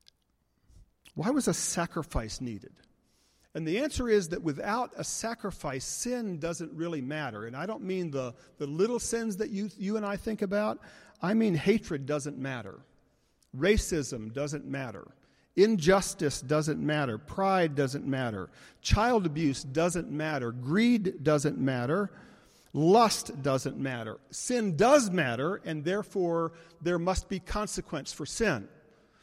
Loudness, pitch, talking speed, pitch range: -30 LUFS, 170 Hz, 140 wpm, 145-205 Hz